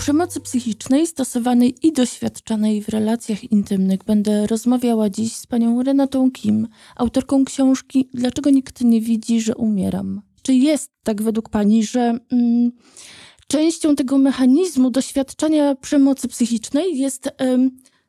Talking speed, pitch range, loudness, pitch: 125 wpm, 225-275 Hz, -19 LUFS, 250 Hz